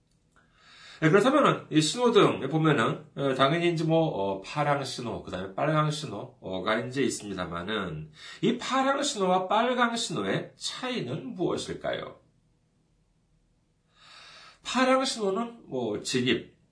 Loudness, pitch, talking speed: -27 LUFS, 155 Hz, 240 characters per minute